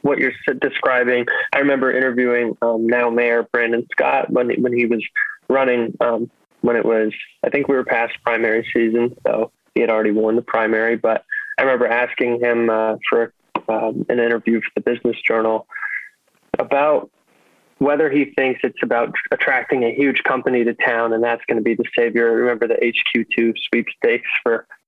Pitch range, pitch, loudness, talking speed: 115-130 Hz, 120 Hz, -18 LUFS, 180 wpm